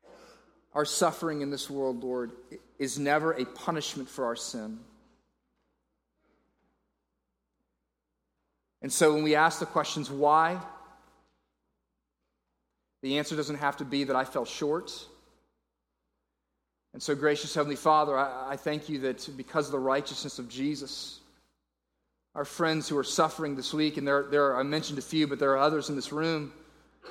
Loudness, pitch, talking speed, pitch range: -29 LUFS, 145 Hz, 150 wpm, 130-155 Hz